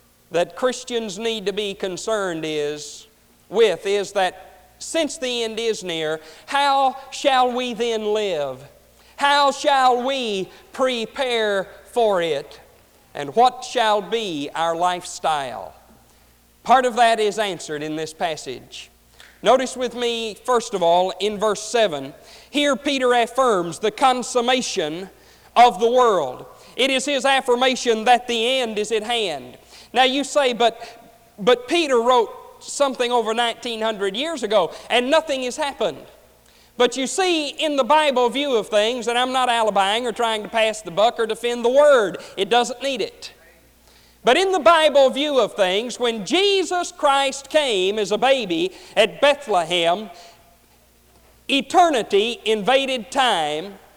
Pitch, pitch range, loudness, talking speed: 235 Hz, 205-265 Hz, -20 LUFS, 145 wpm